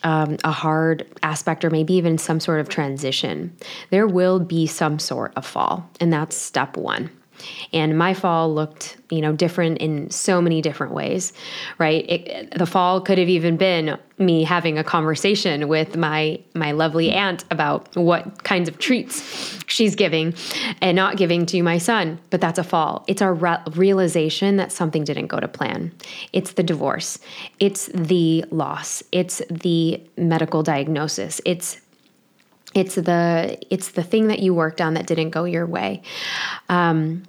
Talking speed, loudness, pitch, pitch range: 165 wpm, -21 LUFS, 170 Hz, 160-185 Hz